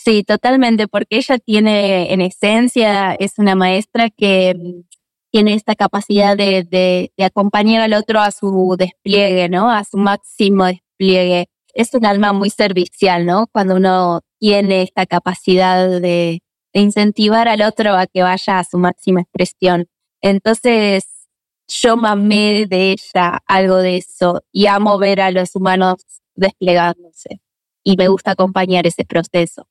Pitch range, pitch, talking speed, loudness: 185-210 Hz, 195 Hz, 145 wpm, -14 LUFS